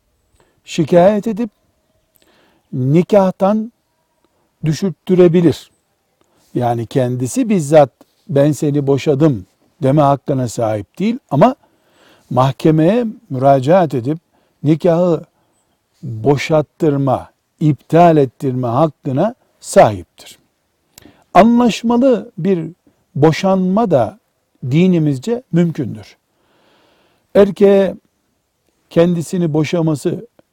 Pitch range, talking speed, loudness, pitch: 140-190 Hz, 65 wpm, -14 LUFS, 160 Hz